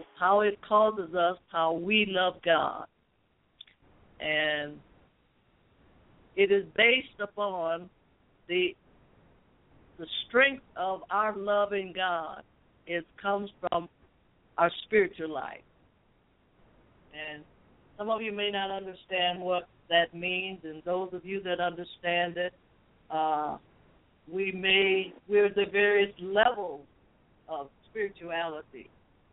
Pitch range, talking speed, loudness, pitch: 170-205 Hz, 105 wpm, -29 LUFS, 185 Hz